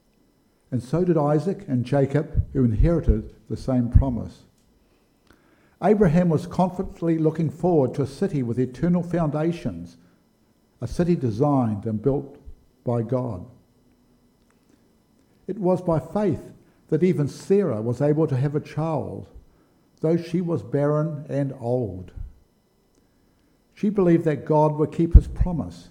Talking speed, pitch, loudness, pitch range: 130 wpm, 145 Hz, -23 LUFS, 120-165 Hz